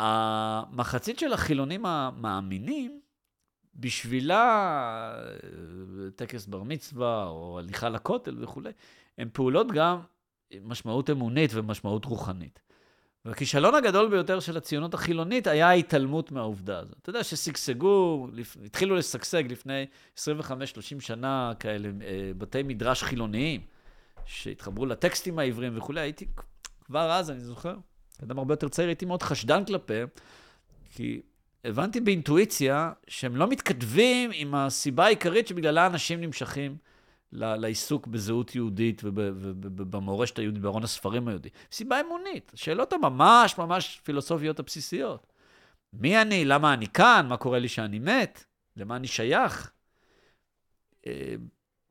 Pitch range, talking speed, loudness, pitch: 110-170 Hz, 115 wpm, -27 LUFS, 135 Hz